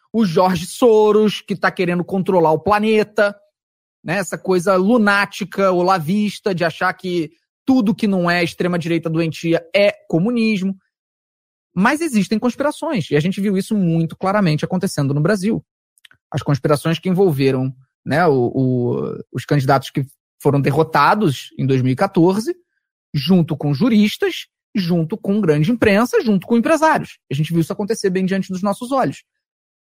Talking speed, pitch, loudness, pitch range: 145 wpm, 190 Hz, -17 LUFS, 165-215 Hz